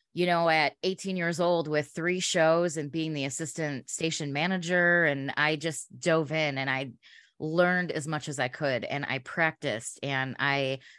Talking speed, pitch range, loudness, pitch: 180 wpm, 140-170 Hz, -28 LUFS, 155 Hz